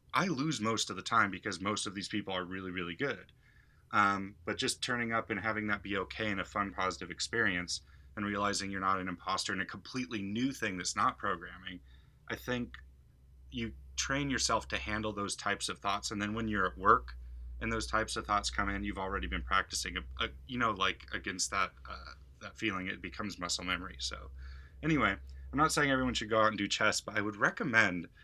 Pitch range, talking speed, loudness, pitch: 90-110 Hz, 215 wpm, -34 LUFS, 100 Hz